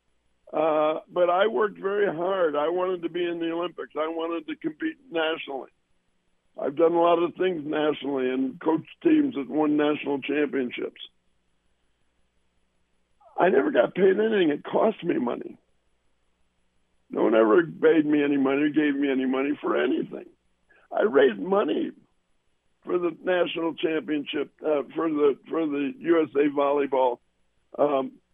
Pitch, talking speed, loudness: 145 Hz, 150 wpm, -25 LUFS